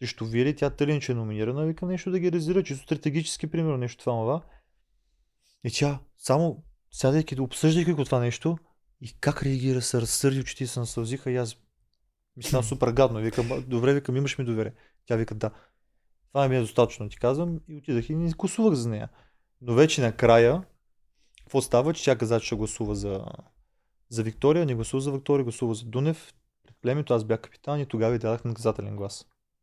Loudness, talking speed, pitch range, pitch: -26 LUFS, 190 wpm, 115-145 Hz, 130 Hz